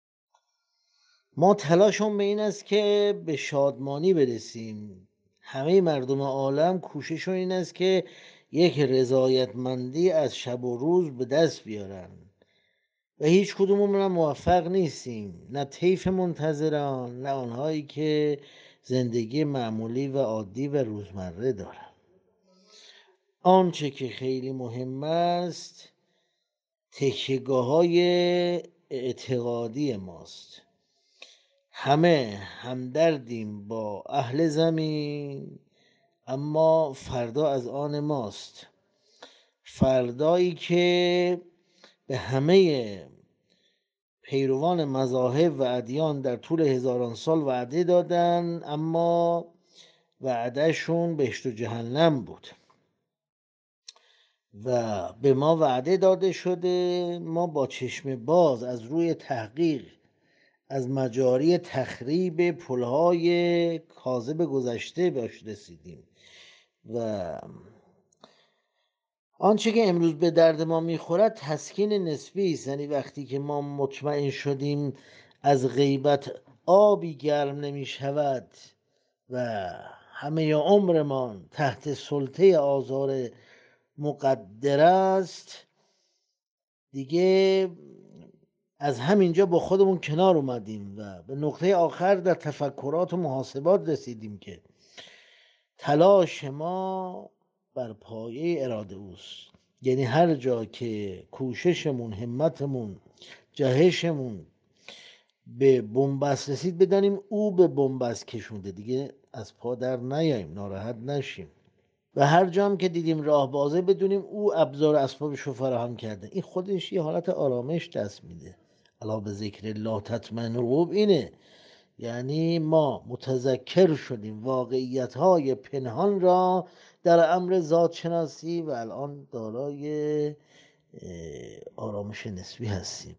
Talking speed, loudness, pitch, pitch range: 100 wpm, -26 LUFS, 145 Hz, 130-175 Hz